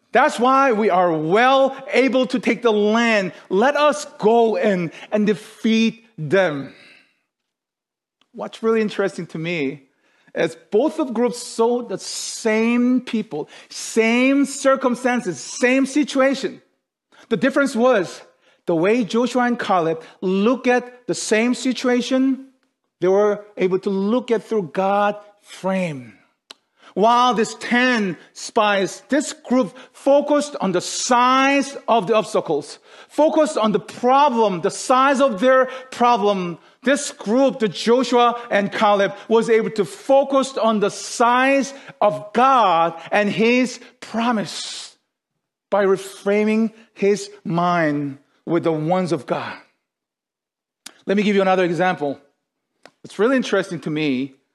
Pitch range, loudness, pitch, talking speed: 195-255 Hz, -19 LUFS, 225 Hz, 130 wpm